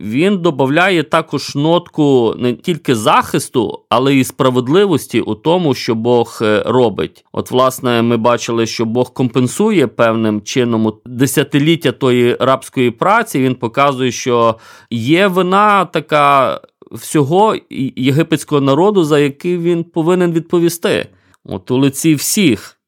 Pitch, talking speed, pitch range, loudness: 135 Hz, 120 wpm, 120-165 Hz, -13 LUFS